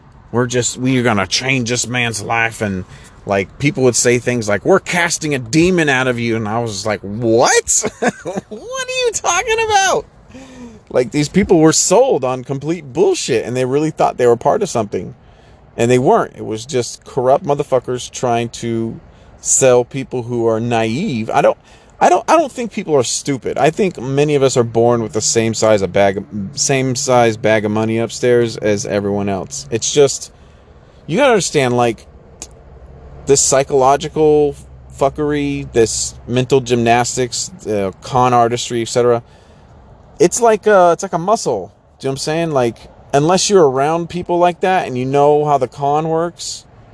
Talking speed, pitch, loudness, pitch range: 180 wpm, 125 Hz, -15 LUFS, 115-150 Hz